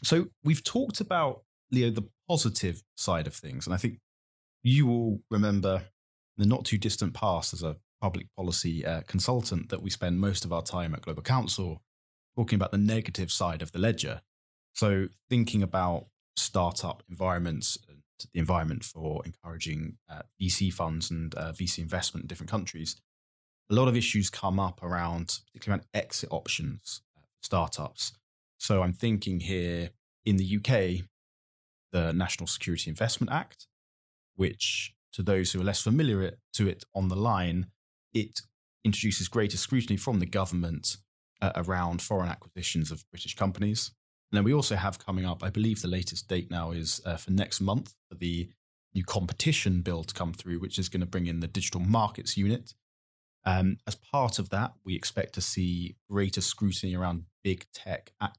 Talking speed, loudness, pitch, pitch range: 175 wpm, -30 LUFS, 95 Hz, 85-110 Hz